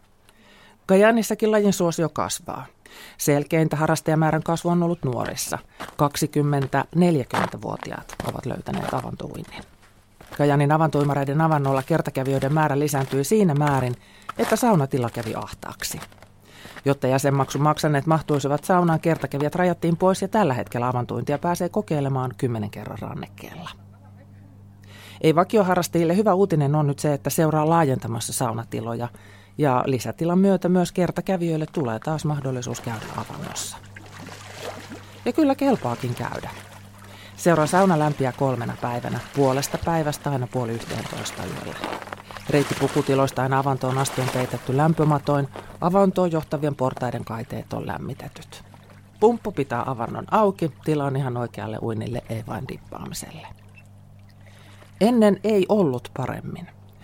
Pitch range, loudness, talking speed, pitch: 120-165 Hz, -23 LUFS, 115 wpm, 140 Hz